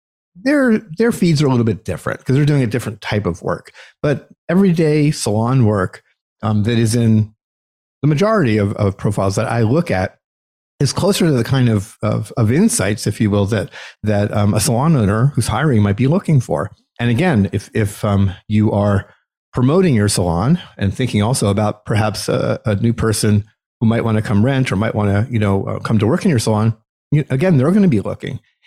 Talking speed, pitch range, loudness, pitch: 215 wpm, 105-135 Hz, -16 LUFS, 110 Hz